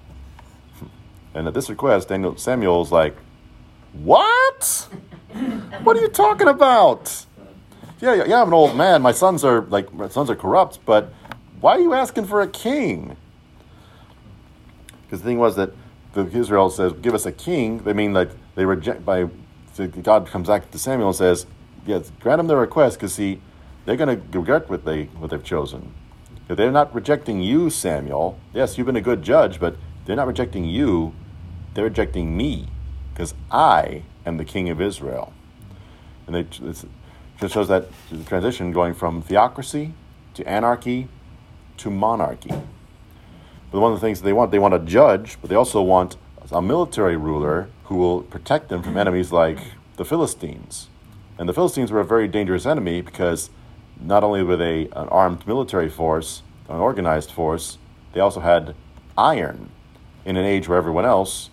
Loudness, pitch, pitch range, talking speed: -20 LUFS, 95 Hz, 85-115 Hz, 170 wpm